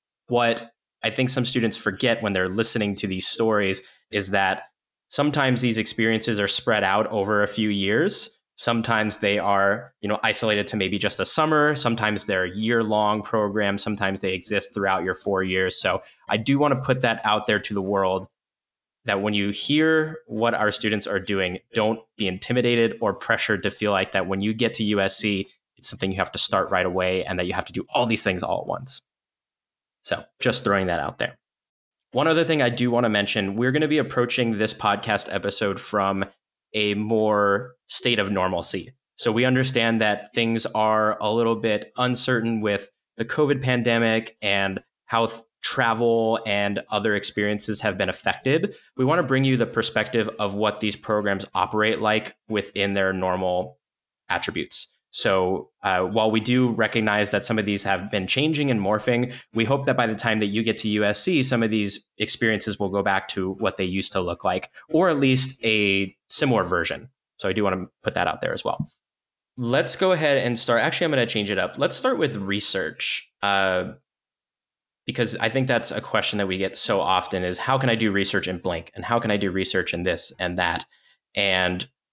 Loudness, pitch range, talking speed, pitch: -23 LUFS, 100-120 Hz, 200 wpm, 105 Hz